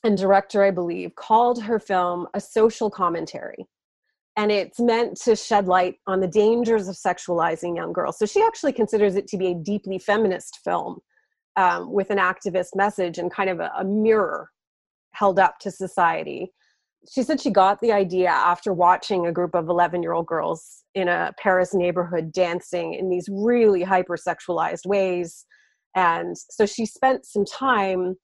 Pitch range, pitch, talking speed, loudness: 180-215 Hz, 195 Hz, 170 wpm, -22 LUFS